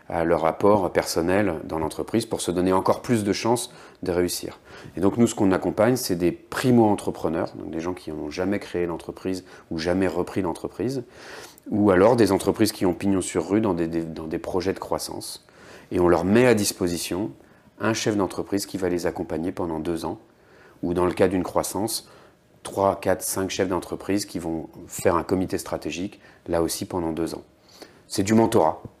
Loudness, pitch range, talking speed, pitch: -24 LUFS, 85-100 Hz, 195 wpm, 90 Hz